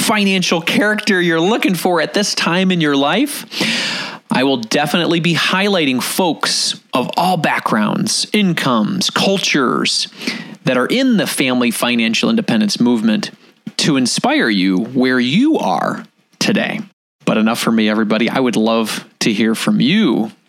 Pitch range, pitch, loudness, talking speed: 150-225 Hz, 200 Hz, -15 LUFS, 145 wpm